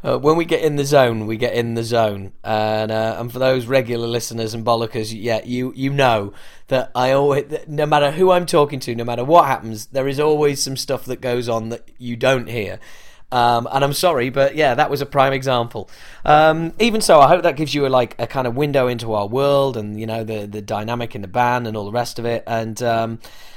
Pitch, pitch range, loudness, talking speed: 125 Hz, 115-140 Hz, -18 LUFS, 245 wpm